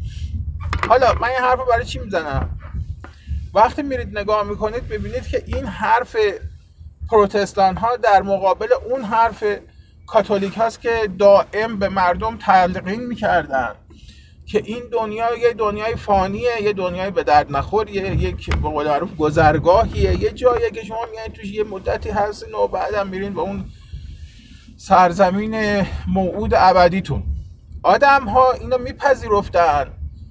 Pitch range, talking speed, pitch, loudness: 145-225 Hz, 125 wpm, 200 Hz, -18 LUFS